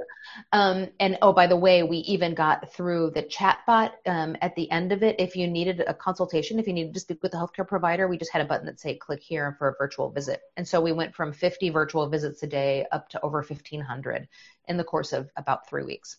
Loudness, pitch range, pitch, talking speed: -26 LUFS, 155-185 Hz, 170 Hz, 250 wpm